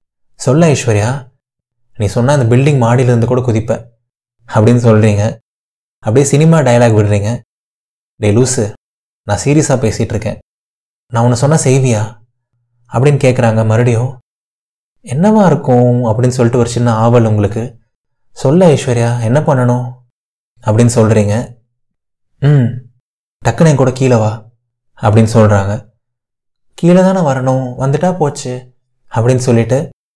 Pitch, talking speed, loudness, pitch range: 120 Hz, 110 wpm, -11 LUFS, 115-130 Hz